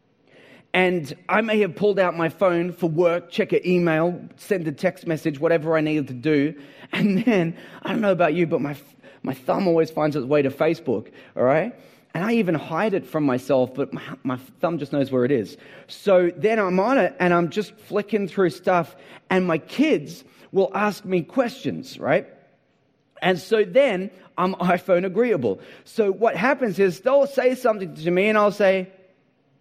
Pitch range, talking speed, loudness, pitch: 160-205 Hz, 190 wpm, -22 LUFS, 180 Hz